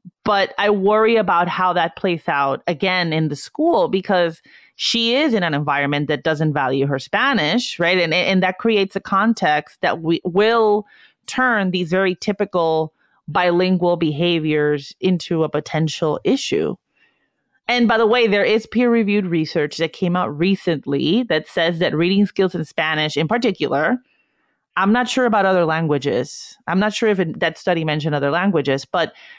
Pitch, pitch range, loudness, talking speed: 180 Hz, 160-215 Hz, -18 LUFS, 165 wpm